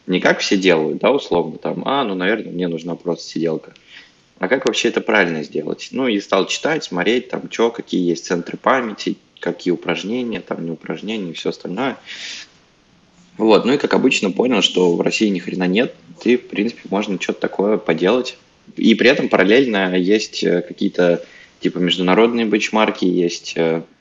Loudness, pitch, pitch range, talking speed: -18 LUFS, 90 Hz, 85-100 Hz, 170 wpm